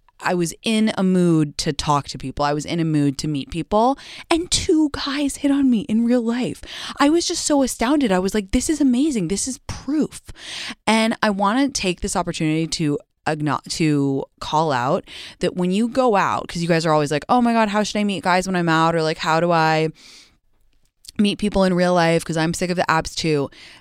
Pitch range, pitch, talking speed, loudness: 160-240 Hz, 185 Hz, 230 wpm, -20 LUFS